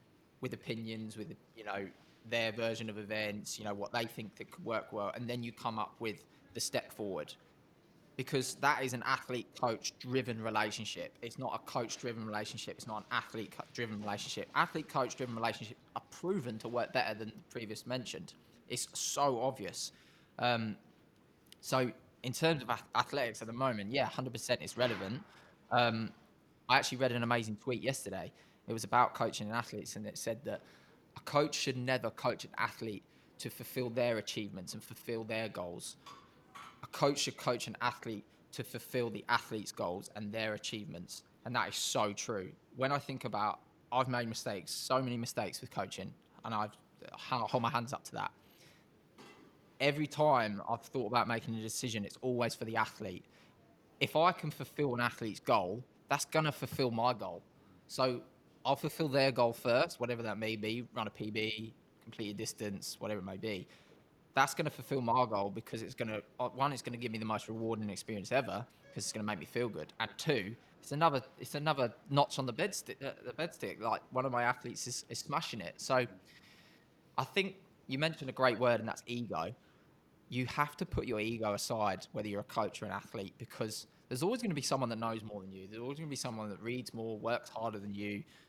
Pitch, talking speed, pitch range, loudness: 120 Hz, 200 wpm, 110-130 Hz, -37 LUFS